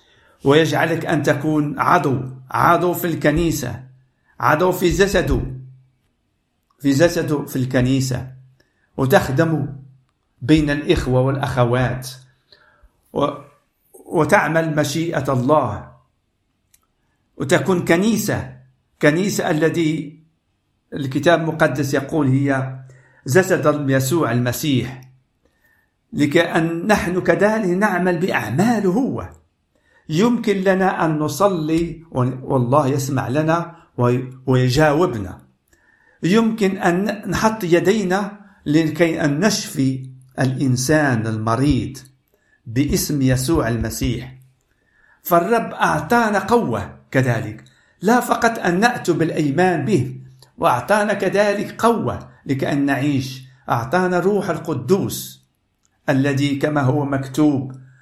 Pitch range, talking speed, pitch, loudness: 130-175 Hz, 85 wpm, 150 Hz, -18 LUFS